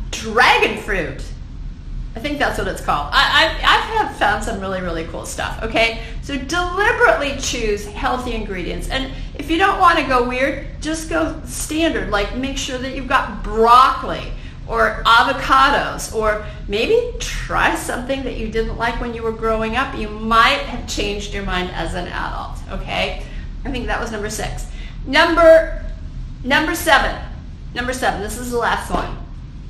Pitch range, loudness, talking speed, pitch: 220-315 Hz, -18 LUFS, 165 wpm, 255 Hz